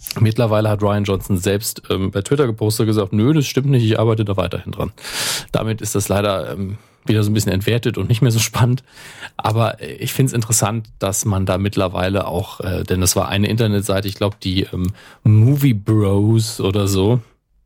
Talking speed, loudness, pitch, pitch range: 200 wpm, -18 LUFS, 105 Hz, 100-120 Hz